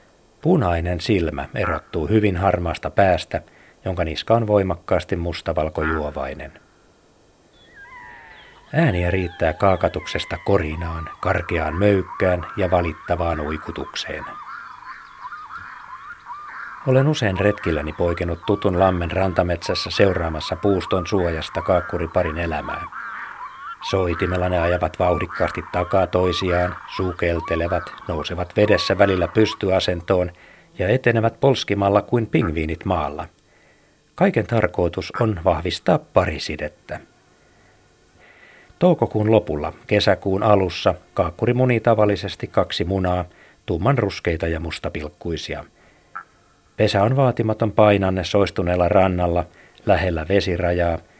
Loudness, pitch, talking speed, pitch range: -21 LUFS, 90 Hz, 85 wpm, 85-105 Hz